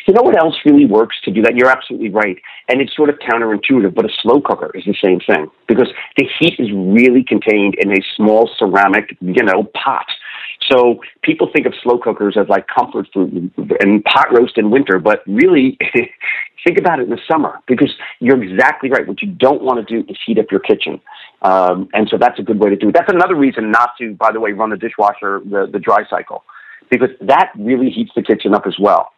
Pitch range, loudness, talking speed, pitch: 105-130 Hz, -13 LUFS, 225 wpm, 115 Hz